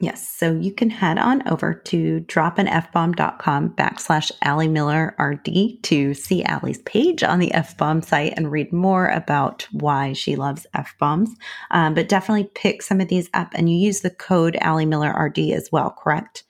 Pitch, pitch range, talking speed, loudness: 170 Hz, 155-195 Hz, 190 wpm, -20 LUFS